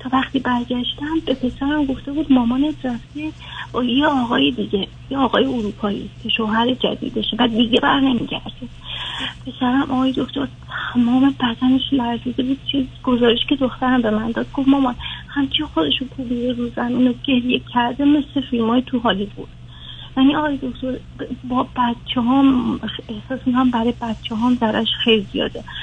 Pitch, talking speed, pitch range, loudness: 250 Hz, 150 wpm, 235-270 Hz, -19 LUFS